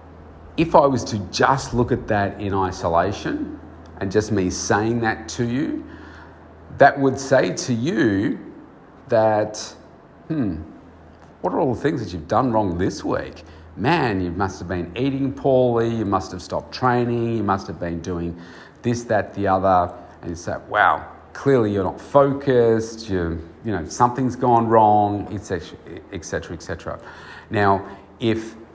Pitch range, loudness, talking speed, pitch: 90-120 Hz, -21 LUFS, 155 wpm, 105 Hz